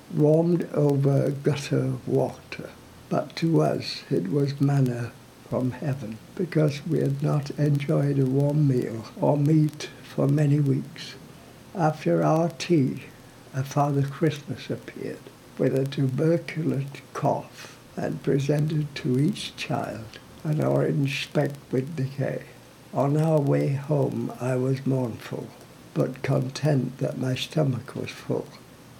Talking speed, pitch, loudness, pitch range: 125 wpm, 140 Hz, -25 LUFS, 130-150 Hz